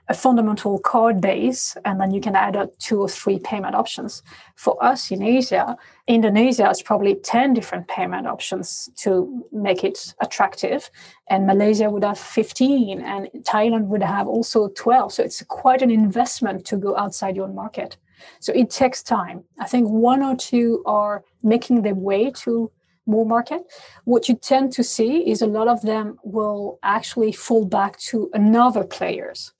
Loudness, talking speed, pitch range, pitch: -20 LUFS, 170 wpm, 200-245 Hz, 220 Hz